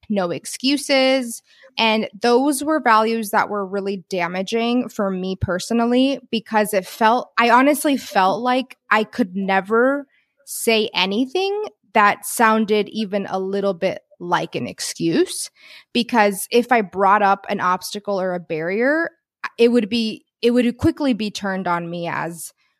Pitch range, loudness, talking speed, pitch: 195-250 Hz, -19 LUFS, 145 wpm, 220 Hz